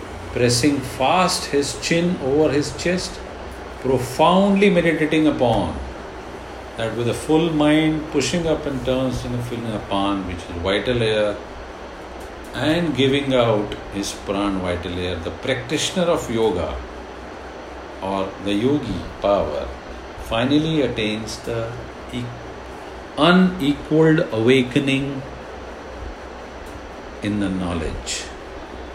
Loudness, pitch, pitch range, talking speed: -20 LUFS, 125 Hz, 100-150 Hz, 105 wpm